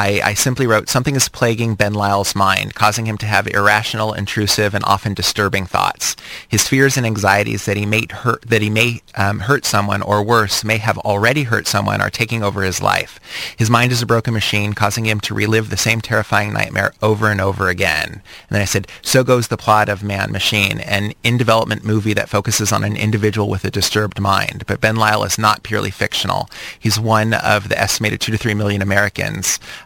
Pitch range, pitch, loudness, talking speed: 100-110 Hz, 105 Hz, -16 LUFS, 205 wpm